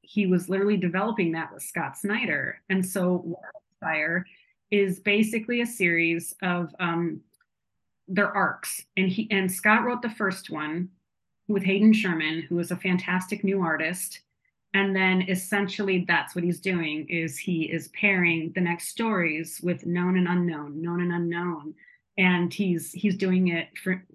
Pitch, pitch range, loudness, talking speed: 185 Hz, 170-195 Hz, -26 LUFS, 155 wpm